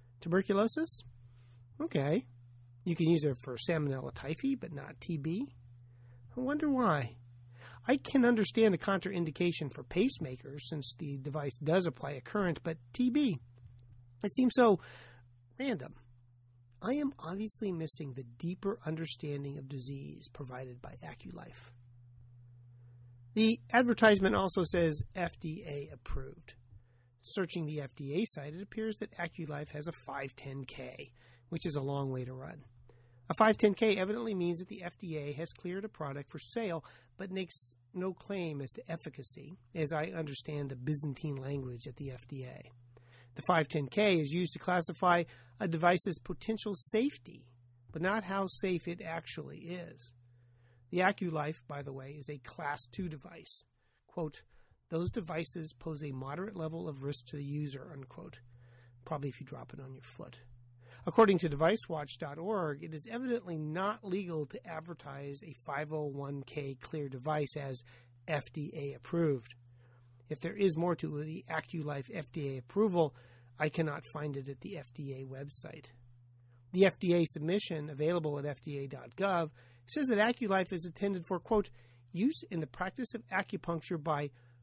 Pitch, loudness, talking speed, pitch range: 150 Hz, -35 LUFS, 145 wpm, 130-180 Hz